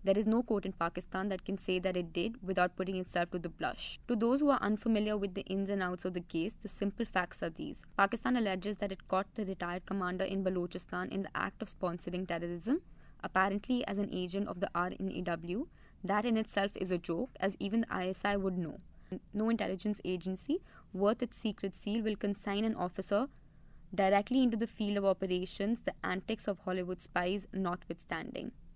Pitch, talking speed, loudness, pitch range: 195 Hz, 195 wpm, -35 LUFS, 180-210 Hz